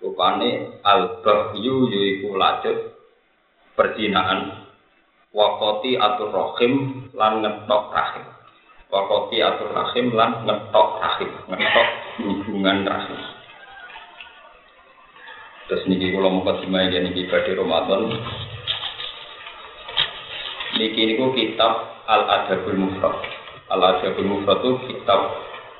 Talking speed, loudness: 100 wpm, -21 LUFS